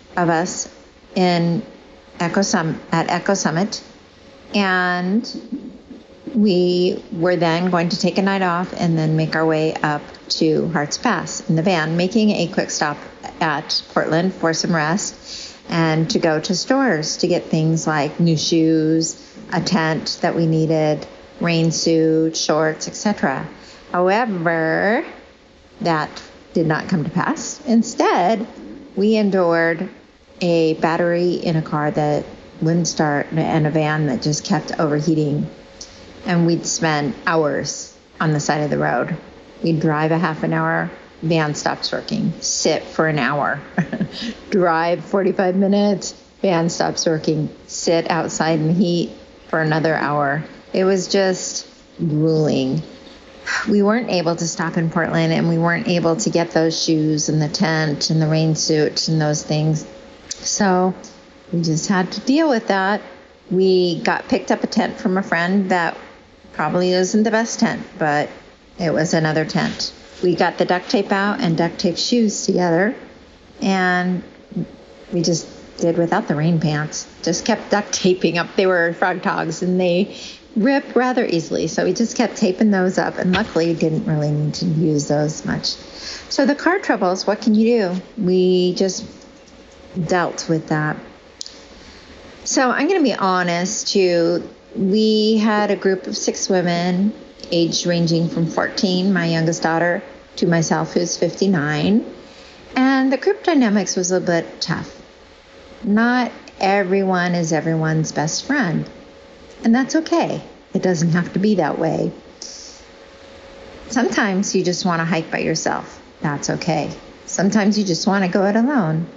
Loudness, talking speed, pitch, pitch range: -19 LUFS, 155 wpm, 180 Hz, 165-200 Hz